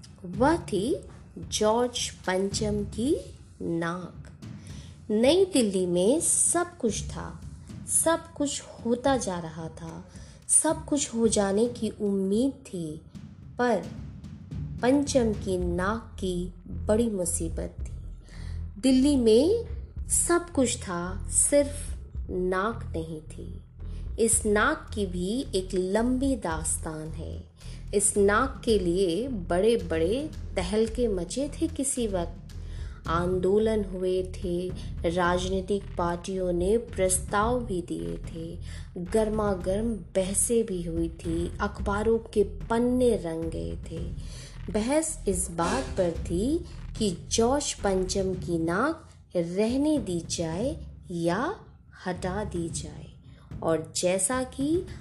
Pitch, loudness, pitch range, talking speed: 190 Hz, -27 LUFS, 165-230 Hz, 110 wpm